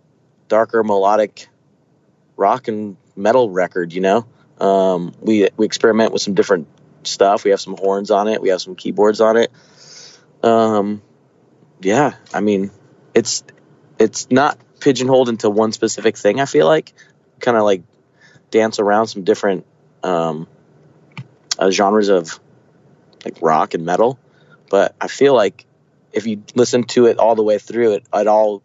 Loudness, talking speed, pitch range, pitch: -16 LUFS, 155 wpm, 100-115 Hz, 105 Hz